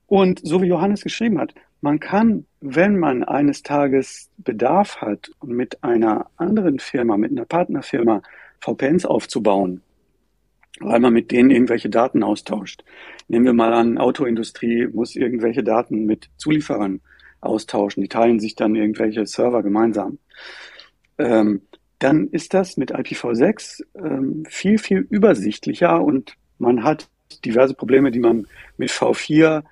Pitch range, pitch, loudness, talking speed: 110-155 Hz, 125 Hz, -19 LUFS, 135 wpm